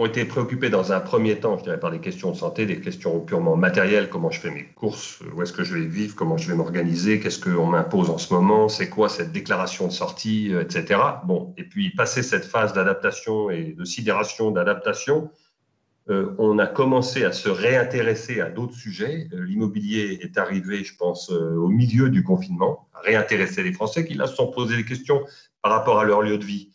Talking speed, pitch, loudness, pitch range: 215 wpm, 120 Hz, -23 LUFS, 105-155 Hz